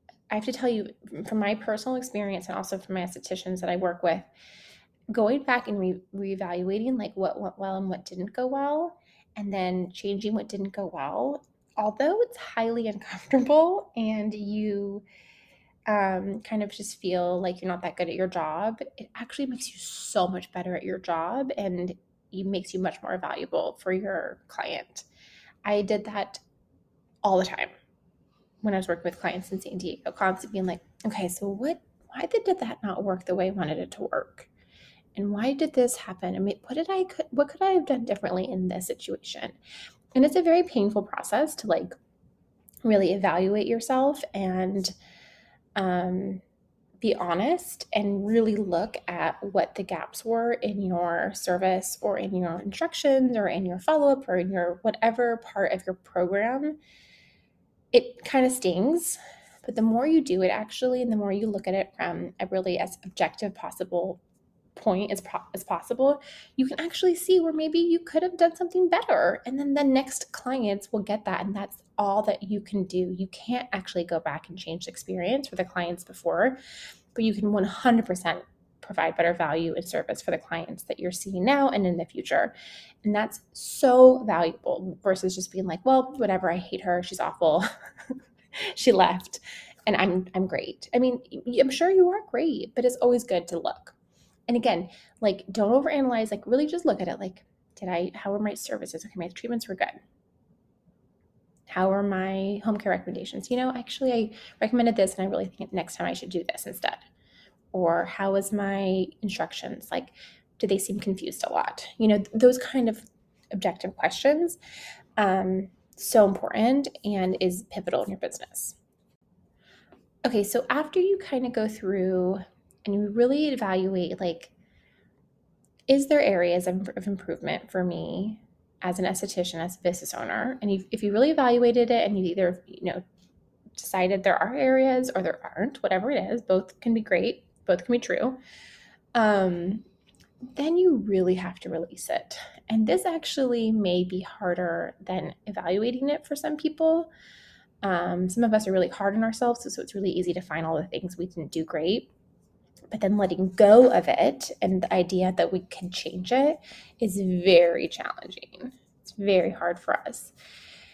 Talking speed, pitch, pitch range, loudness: 185 wpm, 205 Hz, 185-250 Hz, -27 LUFS